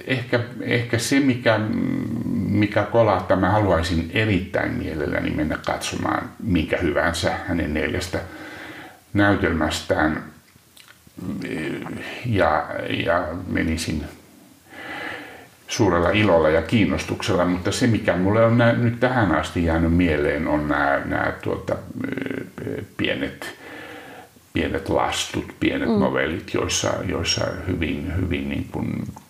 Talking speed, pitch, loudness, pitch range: 100 wpm, 100 Hz, -22 LUFS, 85-115 Hz